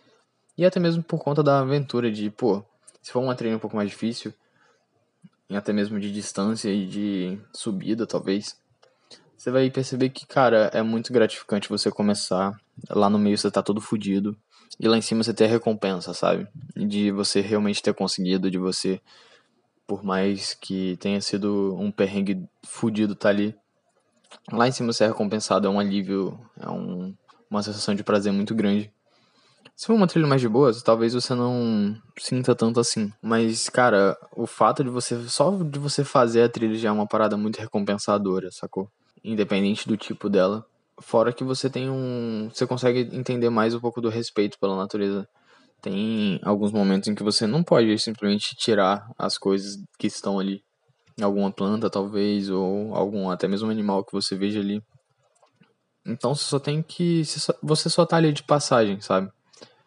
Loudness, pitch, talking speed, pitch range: -24 LUFS, 110 Hz, 175 wpm, 100-120 Hz